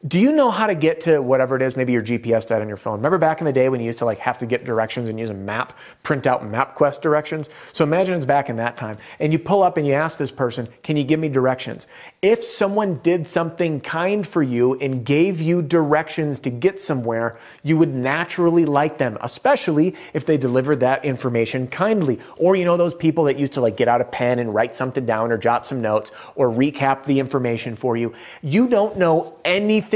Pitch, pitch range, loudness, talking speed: 140 Hz, 125-165 Hz, -20 LUFS, 235 wpm